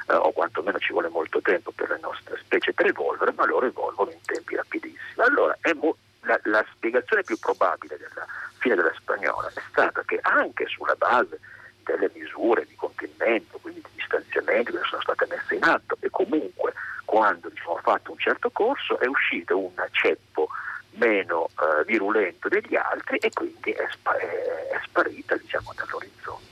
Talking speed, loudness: 175 wpm, -25 LUFS